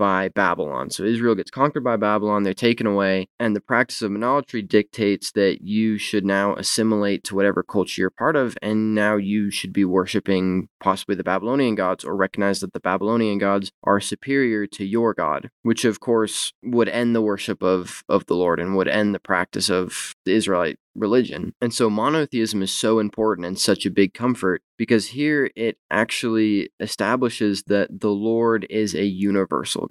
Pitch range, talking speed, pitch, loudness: 100-115 Hz, 185 wpm, 105 Hz, -21 LUFS